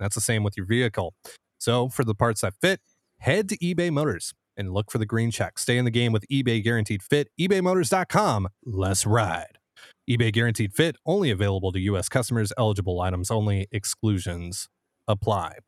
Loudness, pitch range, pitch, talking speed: -25 LUFS, 100-125 Hz, 110 Hz, 175 wpm